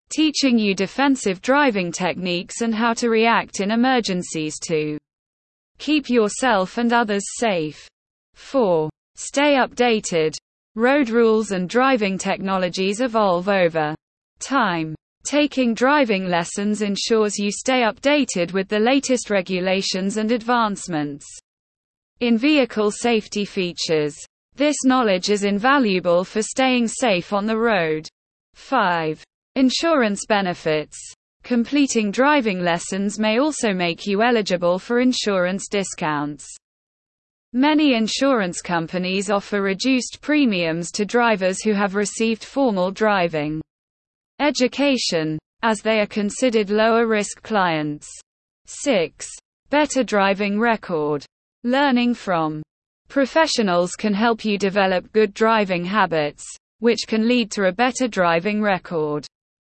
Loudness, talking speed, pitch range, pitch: -20 LUFS, 115 wpm, 180-245 Hz, 210 Hz